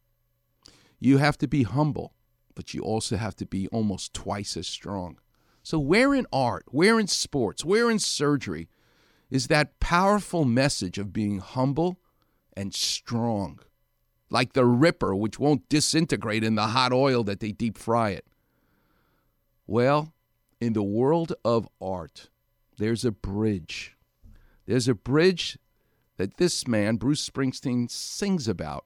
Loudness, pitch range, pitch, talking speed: -25 LUFS, 105-145 Hz, 115 Hz, 140 wpm